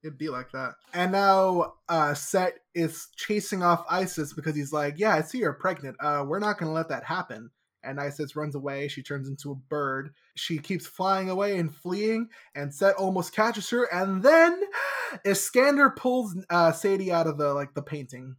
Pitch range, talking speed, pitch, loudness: 145-195 Hz, 195 wpm, 170 Hz, -26 LUFS